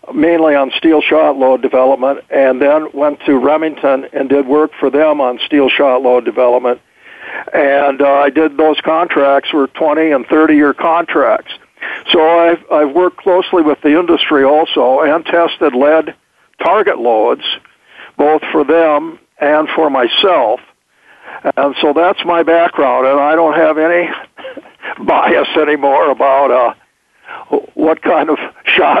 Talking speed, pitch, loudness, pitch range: 145 wpm, 150 Hz, -11 LUFS, 140-160 Hz